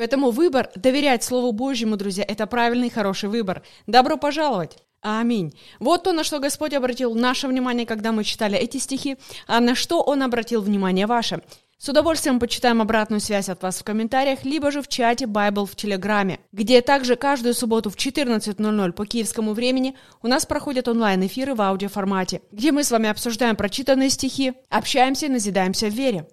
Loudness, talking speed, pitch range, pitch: -21 LUFS, 175 wpm, 210-265 Hz, 235 Hz